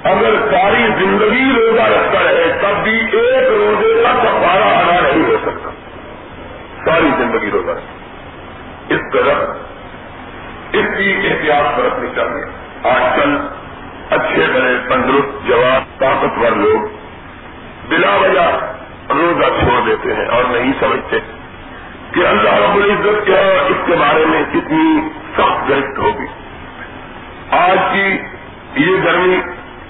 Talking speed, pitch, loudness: 120 wpm, 315 Hz, -13 LUFS